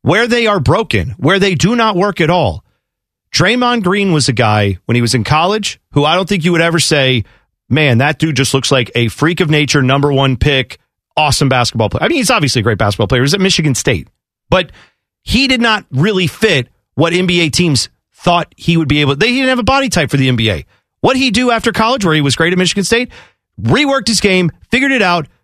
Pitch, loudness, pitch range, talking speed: 155 Hz, -12 LUFS, 130-200 Hz, 235 wpm